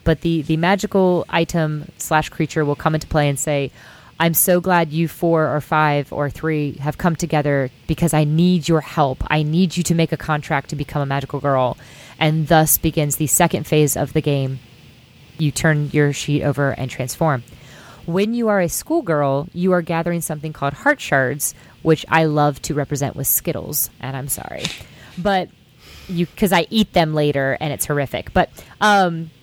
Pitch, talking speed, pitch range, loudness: 155 Hz, 190 wpm, 145-170 Hz, -19 LUFS